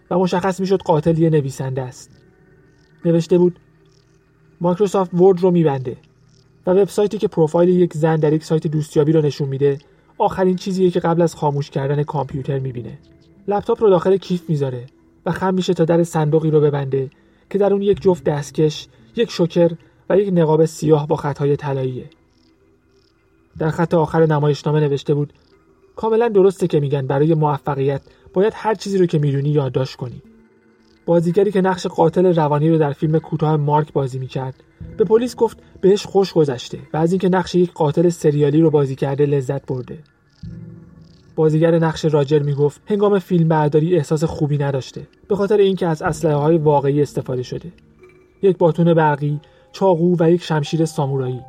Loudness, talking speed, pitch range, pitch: -18 LUFS, 160 wpm, 145-180 Hz, 160 Hz